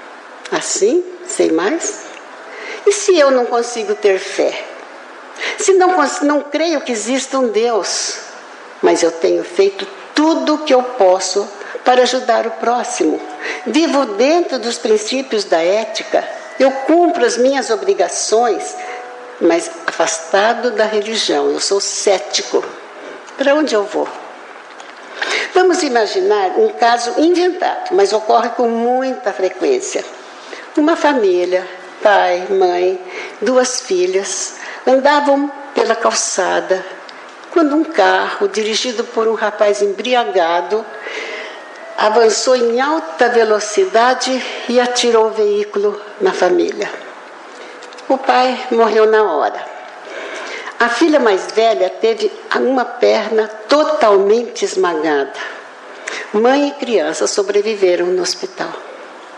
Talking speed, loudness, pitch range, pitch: 110 wpm, -15 LUFS, 210-315 Hz, 240 Hz